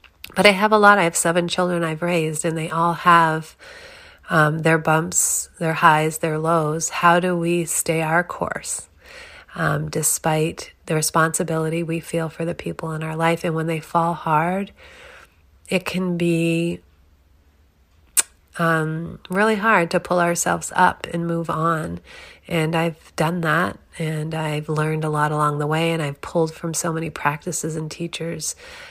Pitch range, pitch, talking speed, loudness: 155-175 Hz, 165 Hz, 165 wpm, -20 LUFS